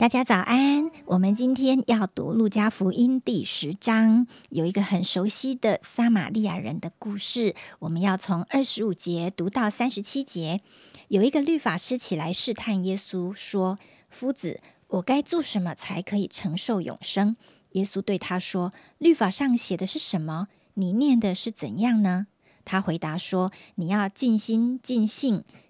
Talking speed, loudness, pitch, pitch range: 245 characters per minute, -25 LUFS, 205 Hz, 185-240 Hz